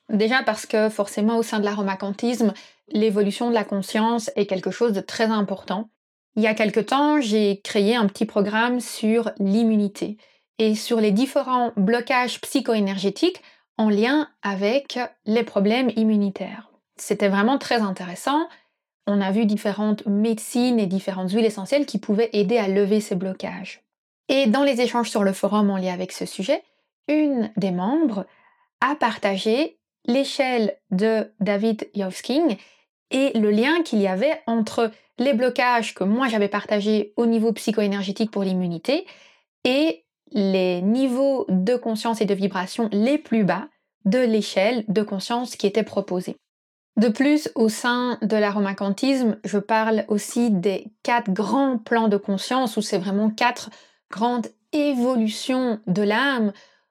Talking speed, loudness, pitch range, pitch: 150 wpm, -22 LUFS, 205-245 Hz, 220 Hz